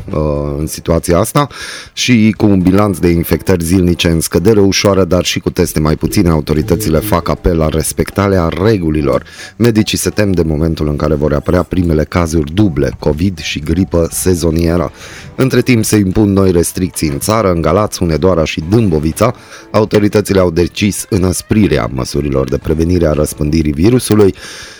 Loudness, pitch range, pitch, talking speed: -12 LUFS, 80-100 Hz, 90 Hz, 155 wpm